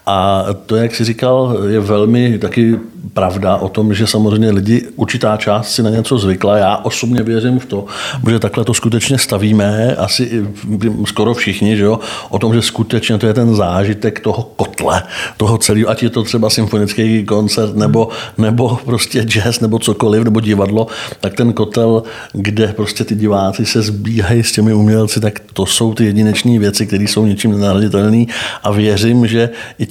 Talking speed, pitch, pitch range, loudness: 175 wpm, 110 Hz, 105-115 Hz, -13 LUFS